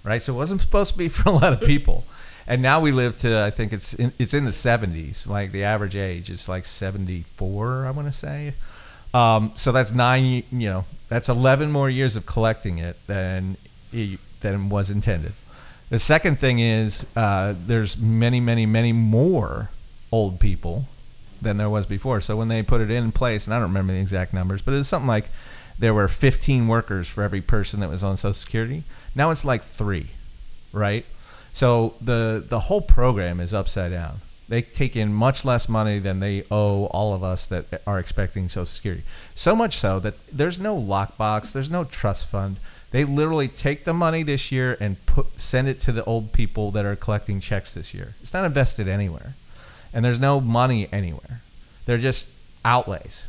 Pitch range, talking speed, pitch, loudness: 100-125 Hz, 195 wpm, 110 Hz, -23 LUFS